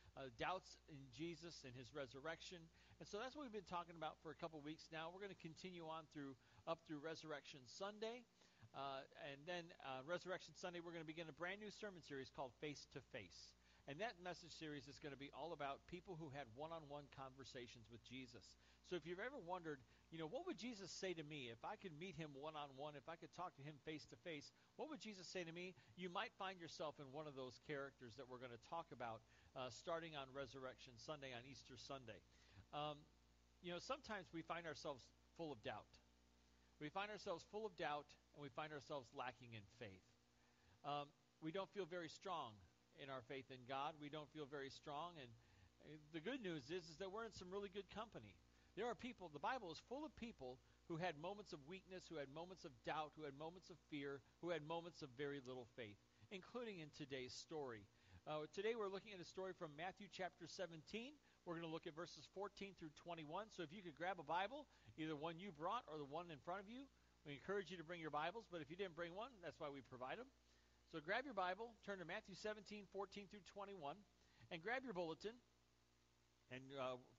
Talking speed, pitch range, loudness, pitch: 220 wpm, 135-185 Hz, -54 LUFS, 160 Hz